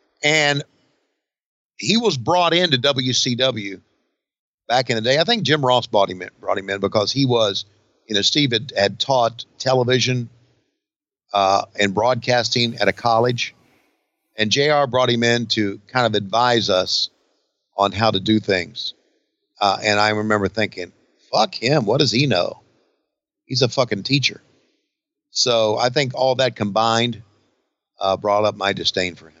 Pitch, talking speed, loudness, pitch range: 120 Hz, 160 wpm, -19 LUFS, 105-130 Hz